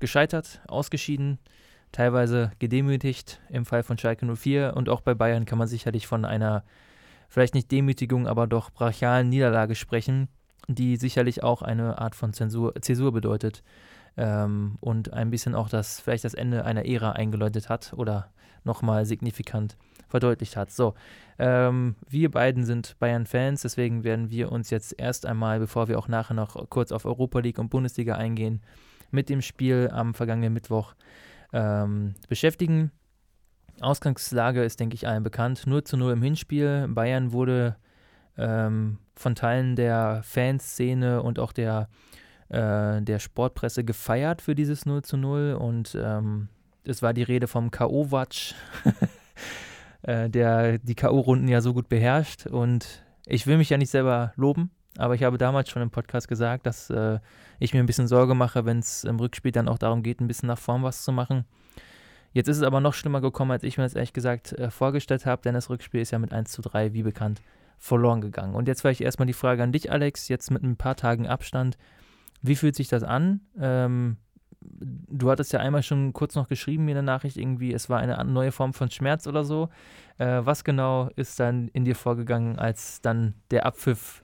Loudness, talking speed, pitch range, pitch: -26 LUFS, 180 wpm, 115-130 Hz, 120 Hz